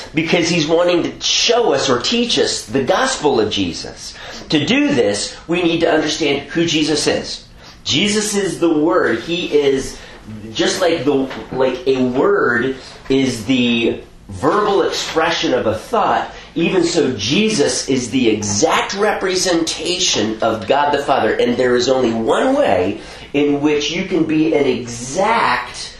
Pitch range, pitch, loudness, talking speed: 130-170 Hz, 145 Hz, -16 LUFS, 150 wpm